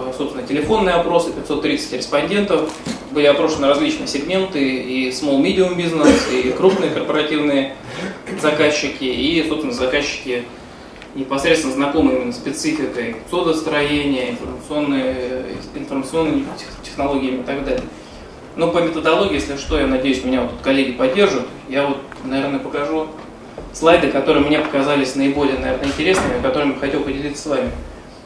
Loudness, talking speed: -18 LUFS, 125 wpm